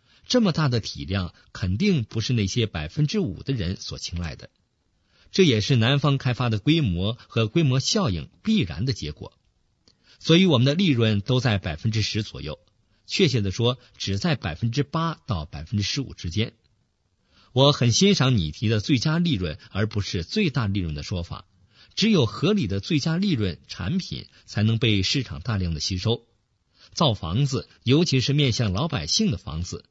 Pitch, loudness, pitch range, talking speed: 115 Hz, -24 LUFS, 100-140 Hz, 265 characters per minute